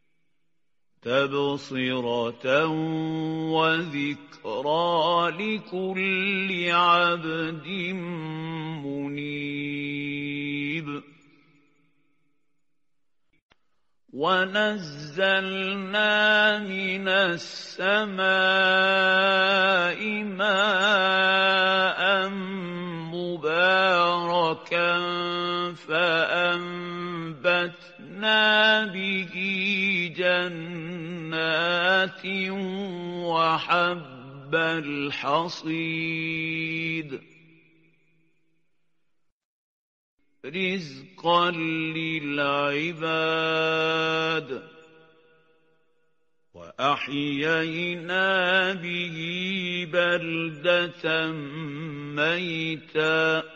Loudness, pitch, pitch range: -24 LUFS, 165 Hz, 160-185 Hz